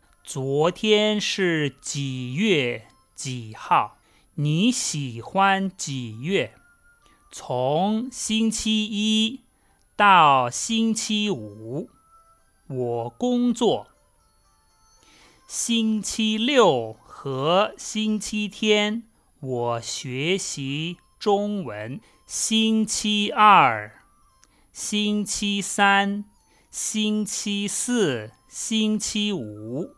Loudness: -23 LUFS